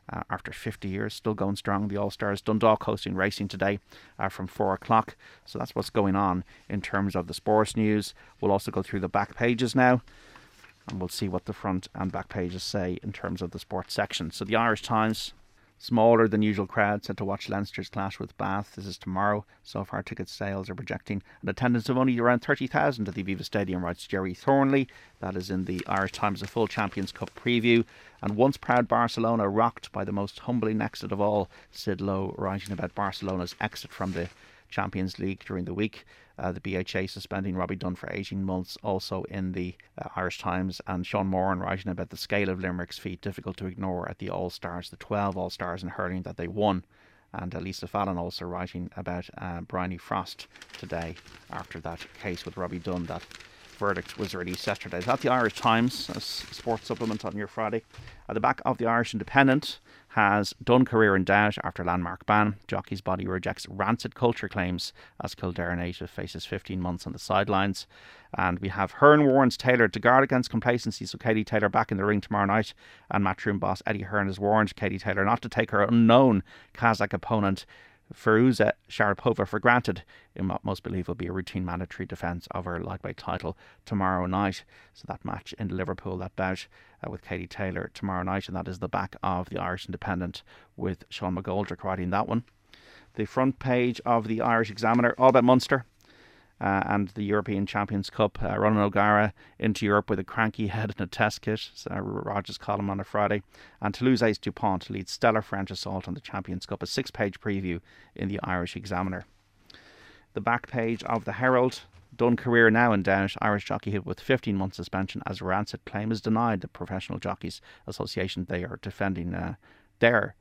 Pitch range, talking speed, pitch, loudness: 95-110 Hz, 200 wpm, 100 Hz, -28 LUFS